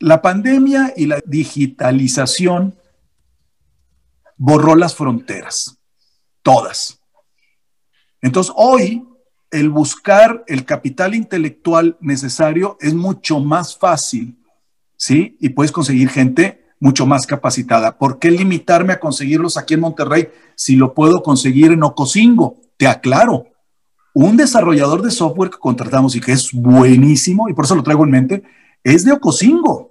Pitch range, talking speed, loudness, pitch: 130-180 Hz, 130 wpm, -13 LUFS, 155 Hz